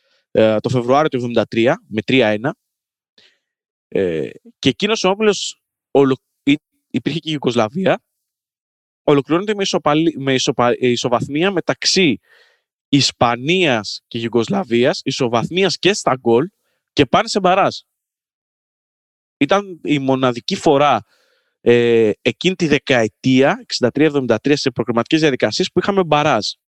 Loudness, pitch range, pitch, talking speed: -17 LUFS, 120-180 Hz, 140 Hz, 110 wpm